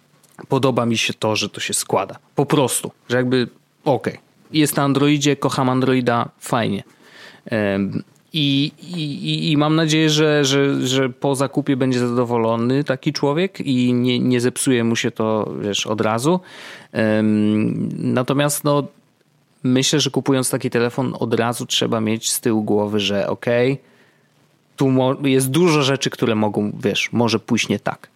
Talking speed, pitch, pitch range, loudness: 150 wpm, 130 Hz, 115-145 Hz, -19 LUFS